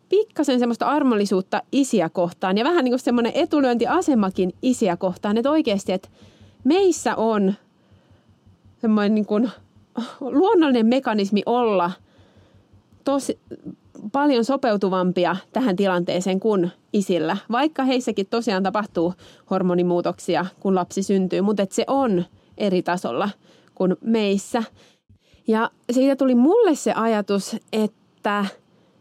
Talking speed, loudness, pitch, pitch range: 110 wpm, -21 LUFS, 210 Hz, 185-250 Hz